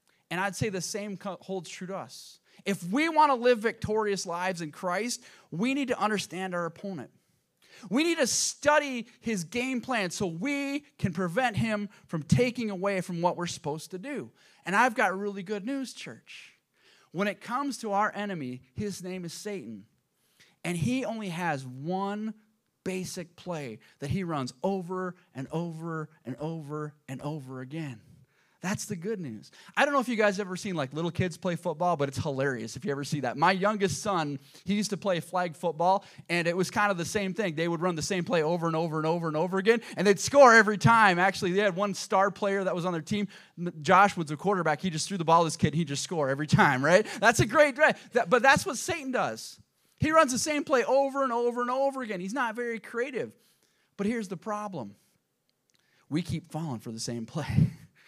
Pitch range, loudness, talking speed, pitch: 165-215 Hz, -28 LUFS, 215 wpm, 190 Hz